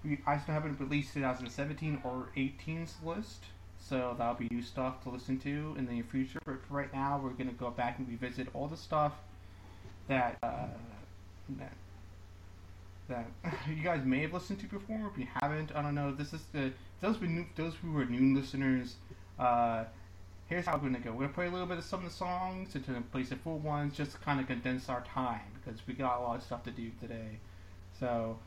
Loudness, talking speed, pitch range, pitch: -37 LUFS, 215 wpm, 115-145 Hz, 130 Hz